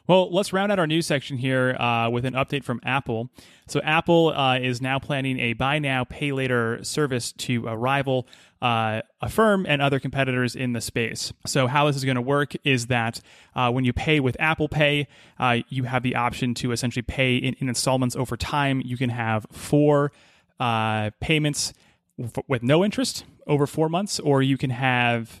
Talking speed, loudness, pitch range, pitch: 200 wpm, -23 LUFS, 120-145 Hz, 130 Hz